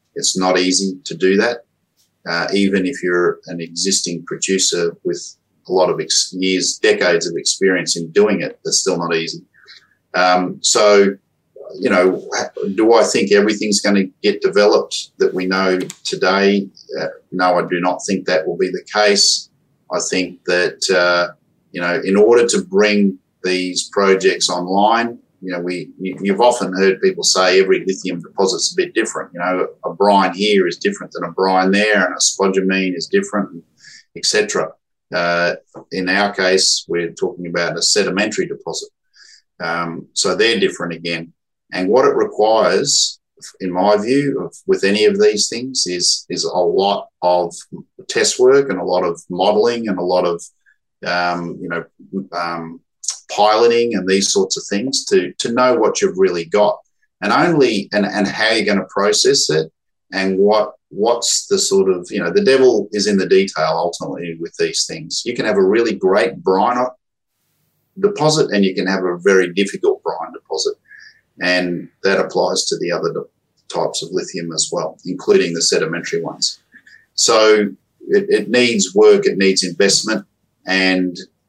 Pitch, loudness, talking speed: 100 Hz, -16 LUFS, 170 wpm